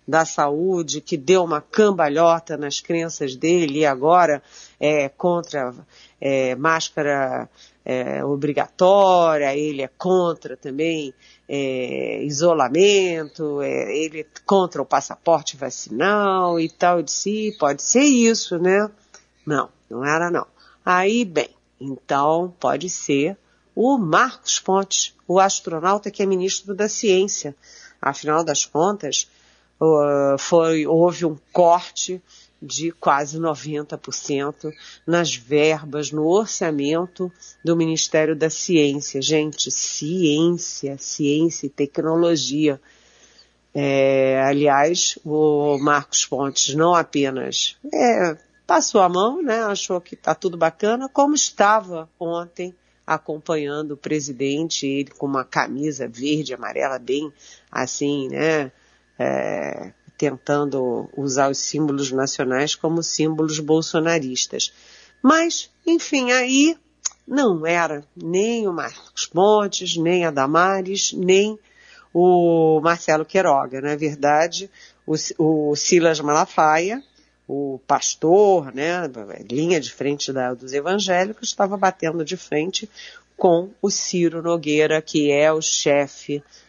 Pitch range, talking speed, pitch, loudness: 145-185 Hz, 115 wpm, 160 Hz, -20 LUFS